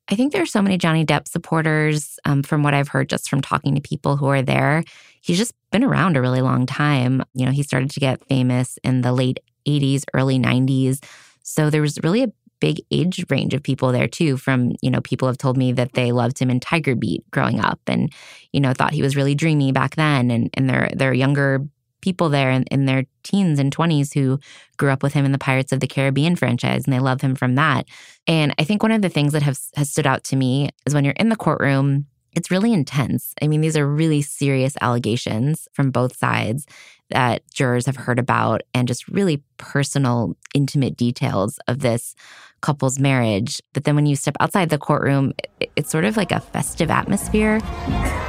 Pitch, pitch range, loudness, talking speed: 140 Hz, 130-155 Hz, -20 LUFS, 220 wpm